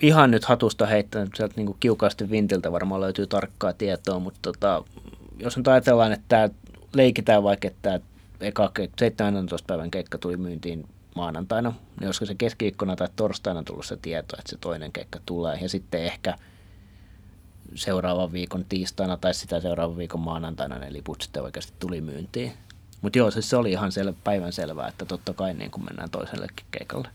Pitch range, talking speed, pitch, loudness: 90-105 Hz, 175 wpm, 95 Hz, -26 LUFS